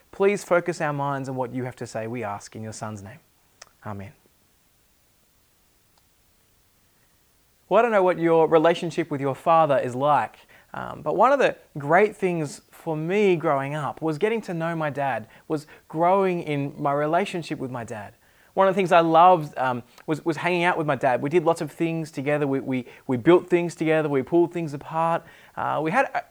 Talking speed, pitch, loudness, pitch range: 200 wpm, 155 Hz, -23 LUFS, 135-170 Hz